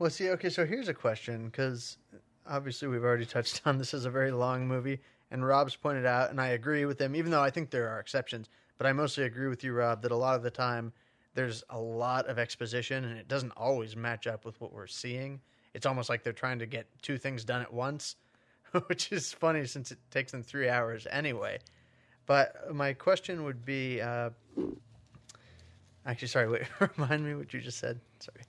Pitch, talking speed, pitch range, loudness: 130 Hz, 215 wpm, 120-140 Hz, -33 LUFS